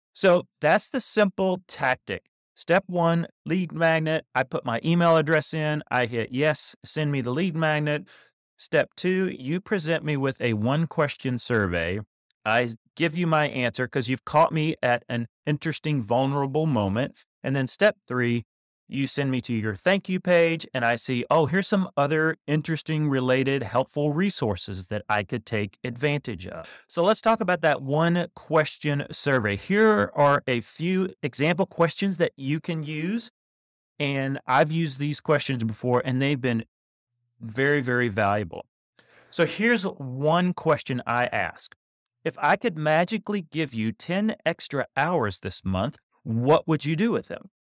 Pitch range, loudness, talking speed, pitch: 125-165 Hz, -25 LUFS, 160 wpm, 150 Hz